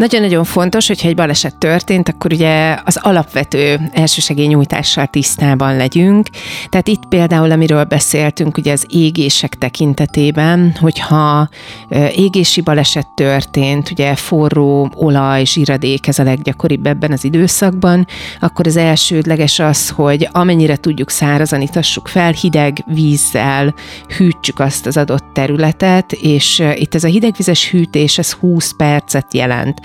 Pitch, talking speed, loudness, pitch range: 155 Hz, 130 wpm, -12 LUFS, 145-170 Hz